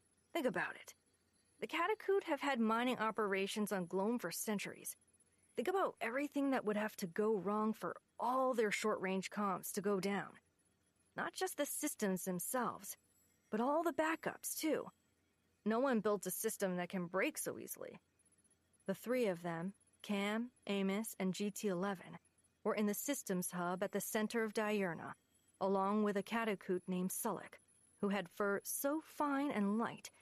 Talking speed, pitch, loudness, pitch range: 165 wpm, 210 Hz, -39 LUFS, 195-240 Hz